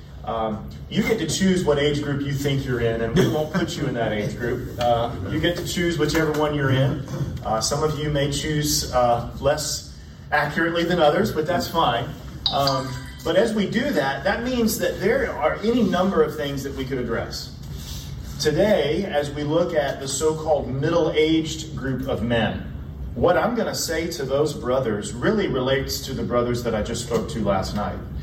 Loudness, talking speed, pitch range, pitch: -23 LUFS, 205 wpm, 120-160 Hz, 145 Hz